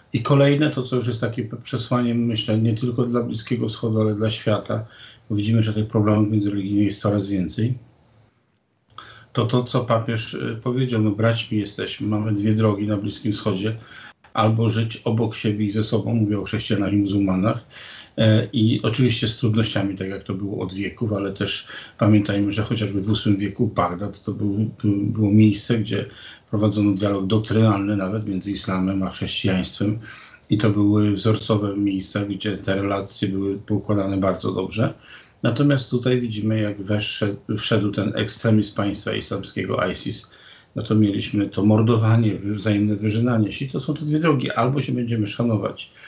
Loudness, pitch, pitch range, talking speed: -22 LUFS, 110 Hz, 100-115 Hz, 165 wpm